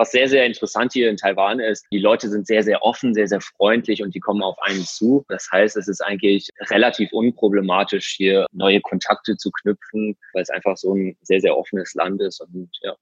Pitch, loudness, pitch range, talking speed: 105 Hz, -19 LUFS, 95-110 Hz, 220 wpm